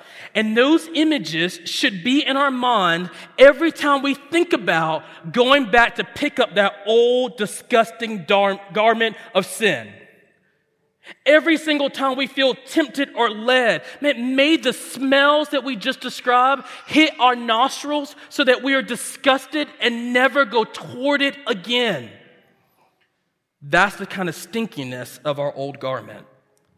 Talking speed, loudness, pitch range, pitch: 145 wpm, -19 LUFS, 200-275 Hz, 245 Hz